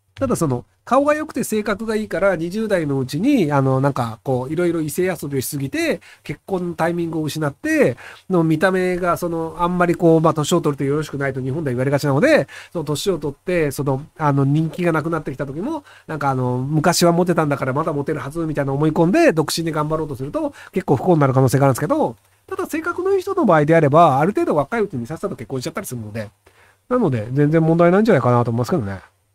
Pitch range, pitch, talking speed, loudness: 140-180 Hz, 160 Hz, 490 characters per minute, -19 LUFS